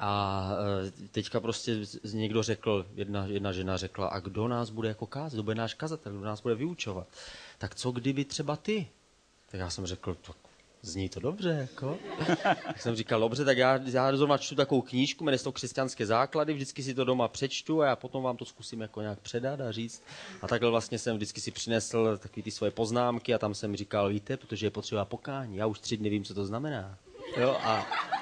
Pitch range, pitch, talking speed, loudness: 100-130 Hz, 115 Hz, 210 wpm, -32 LUFS